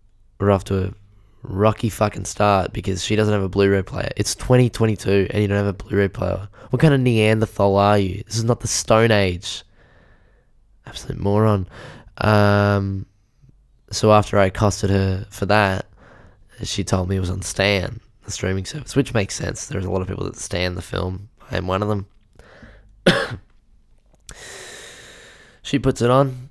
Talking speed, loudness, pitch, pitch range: 175 wpm, -20 LUFS, 100 Hz, 95-110 Hz